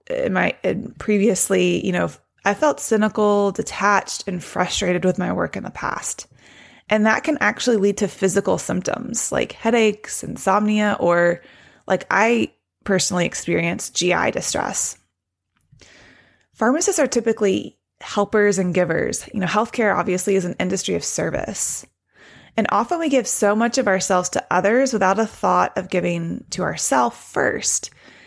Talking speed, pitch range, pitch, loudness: 145 wpm, 190-225 Hz, 205 Hz, -20 LUFS